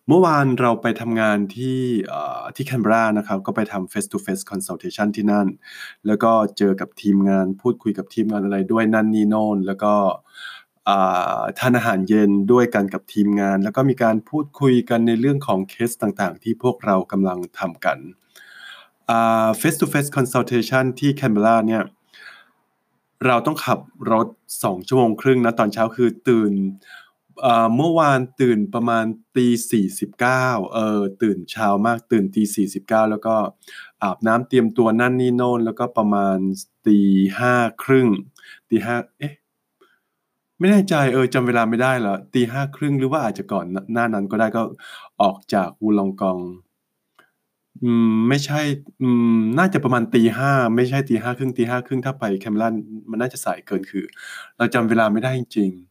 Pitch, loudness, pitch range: 115 Hz, -19 LUFS, 105-125 Hz